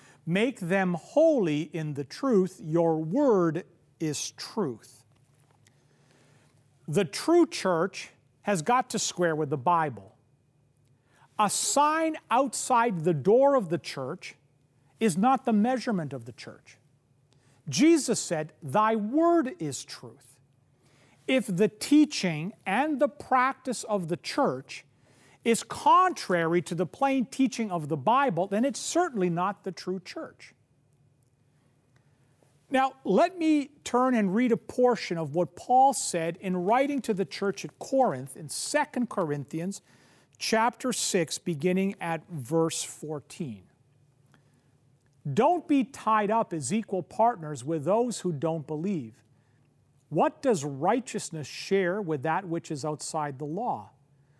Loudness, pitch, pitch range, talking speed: -27 LUFS, 170 Hz, 140-225 Hz, 130 wpm